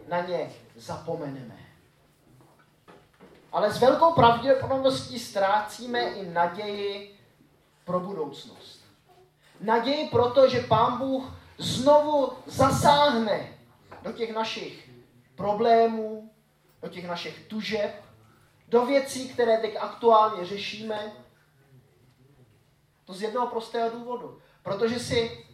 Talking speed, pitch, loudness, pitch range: 95 wpm, 215 Hz, -25 LUFS, 170-240 Hz